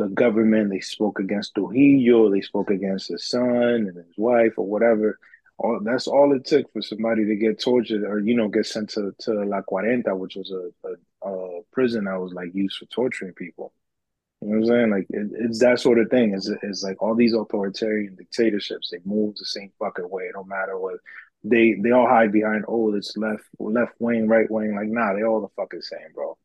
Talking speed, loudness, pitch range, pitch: 215 wpm, -22 LUFS, 100-115 Hz, 110 Hz